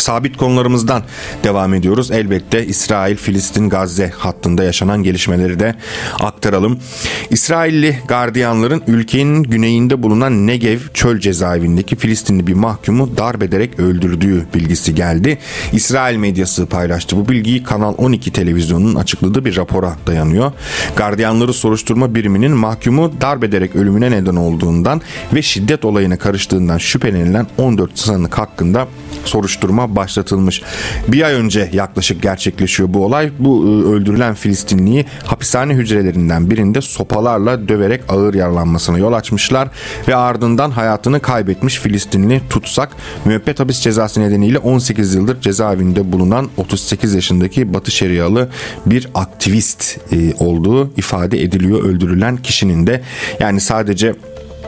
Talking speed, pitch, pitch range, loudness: 115 wpm, 105 Hz, 95-120 Hz, -13 LUFS